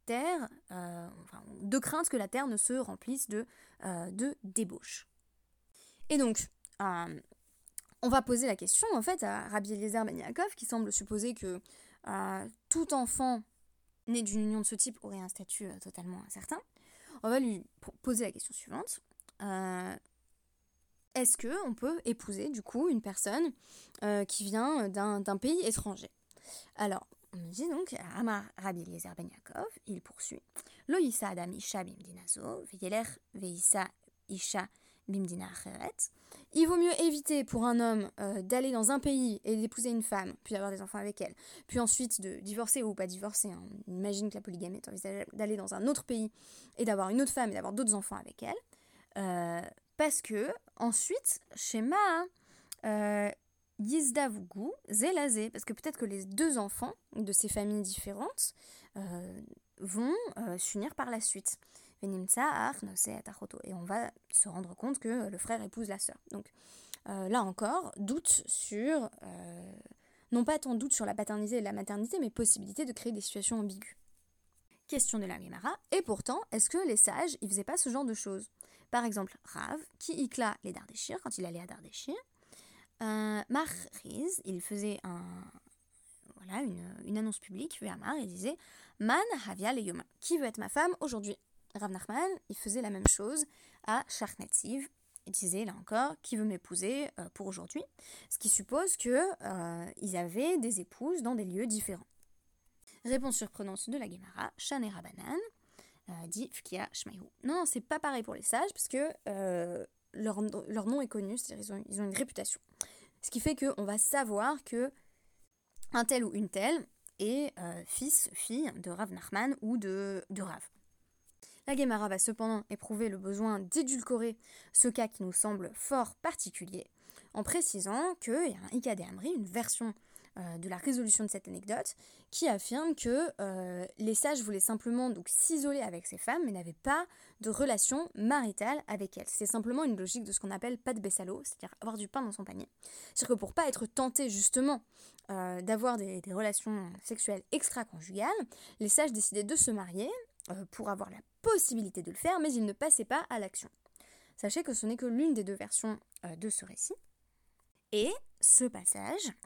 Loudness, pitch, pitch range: -34 LUFS, 220 Hz, 195-265 Hz